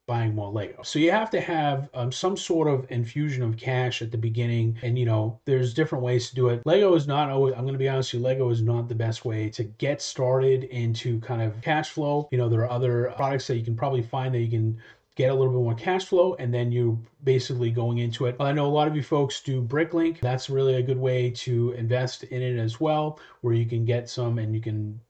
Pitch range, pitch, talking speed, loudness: 120-140 Hz, 125 Hz, 260 wpm, -25 LUFS